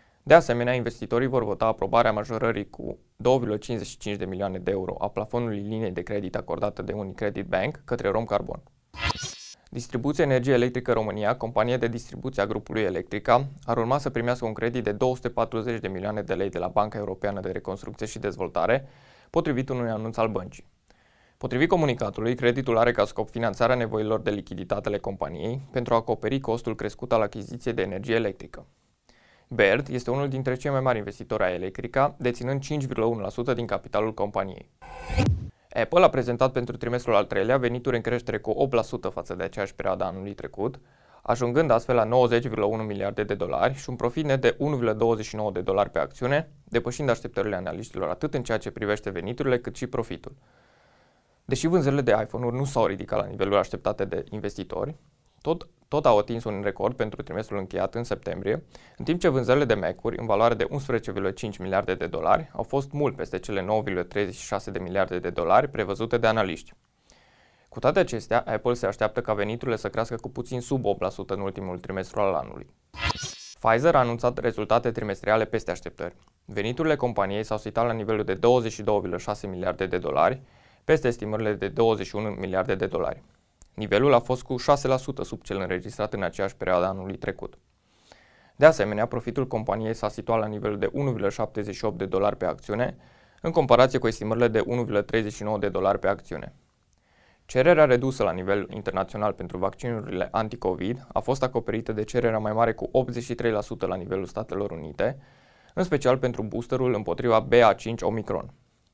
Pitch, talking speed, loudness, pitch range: 115 Hz, 165 wpm, -26 LUFS, 105-125 Hz